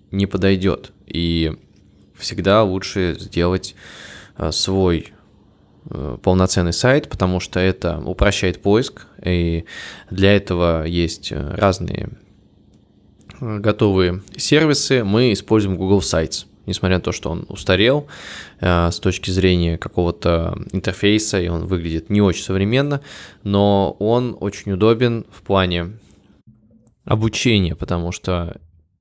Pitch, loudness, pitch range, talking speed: 95 Hz, -18 LUFS, 85-105 Hz, 105 wpm